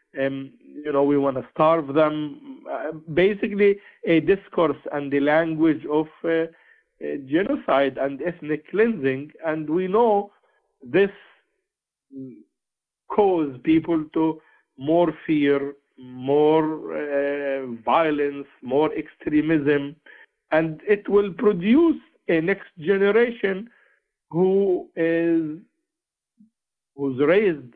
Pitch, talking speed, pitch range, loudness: 160 Hz, 100 wpm, 145-200 Hz, -22 LUFS